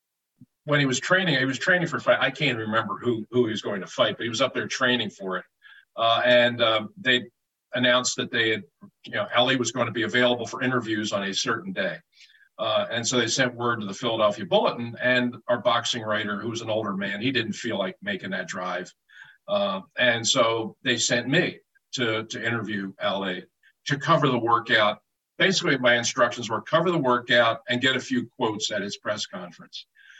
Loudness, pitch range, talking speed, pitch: -24 LUFS, 115-130 Hz, 210 wpm, 120 Hz